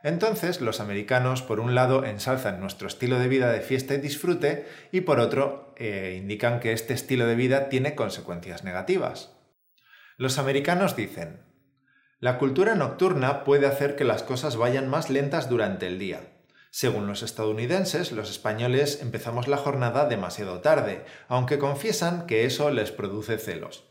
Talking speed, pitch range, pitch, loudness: 155 wpm, 115-145 Hz, 130 Hz, -26 LUFS